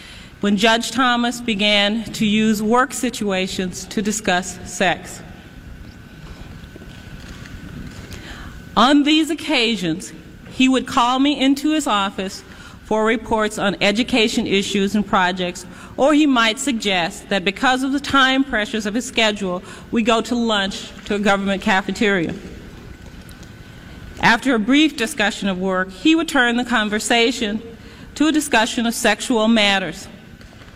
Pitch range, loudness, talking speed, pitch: 200-250 Hz, -18 LUFS, 130 wpm, 220 Hz